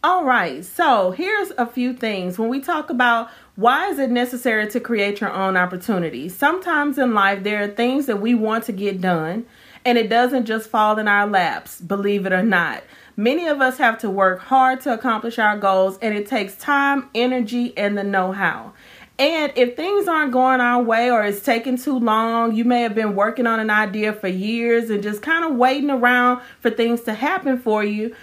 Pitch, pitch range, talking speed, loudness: 235 Hz, 210-255 Hz, 205 wpm, -19 LUFS